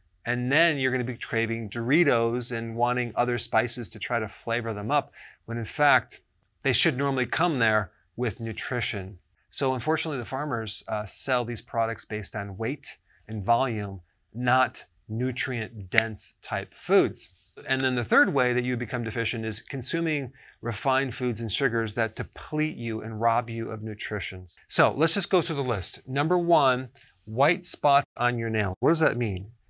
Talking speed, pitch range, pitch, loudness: 175 wpm, 110-130 Hz, 120 Hz, -27 LUFS